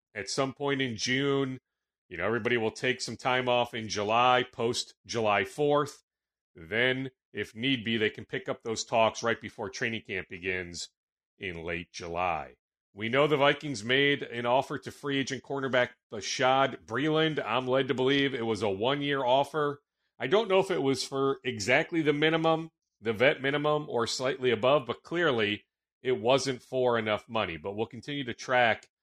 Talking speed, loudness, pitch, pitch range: 180 wpm, -29 LUFS, 130 Hz, 115-140 Hz